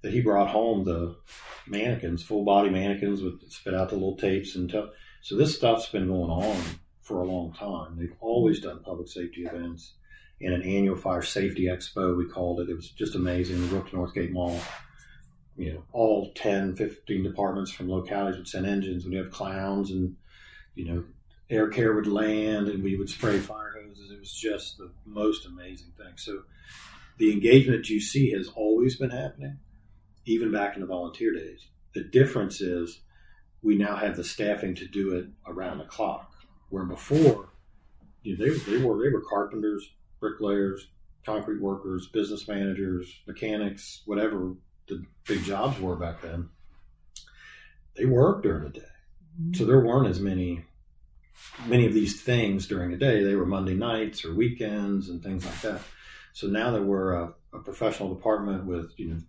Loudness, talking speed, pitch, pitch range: -28 LUFS, 175 wpm, 95 Hz, 90-105 Hz